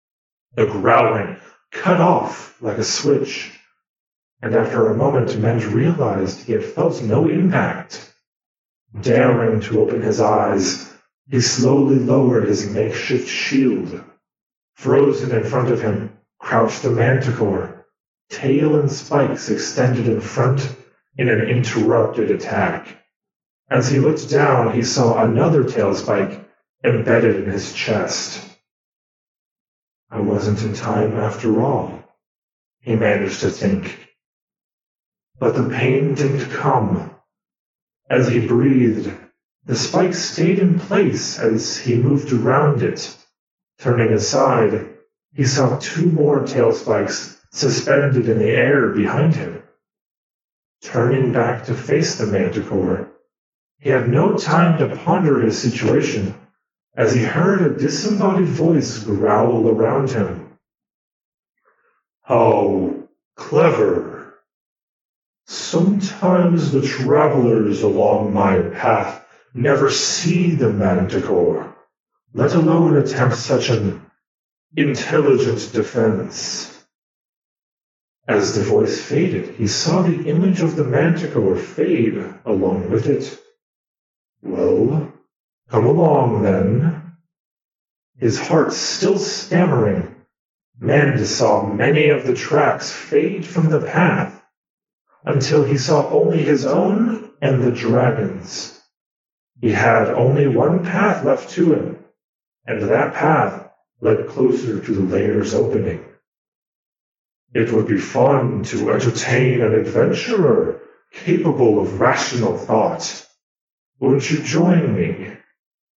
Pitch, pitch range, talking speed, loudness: 135 Hz, 120-165 Hz, 115 wpm, -17 LUFS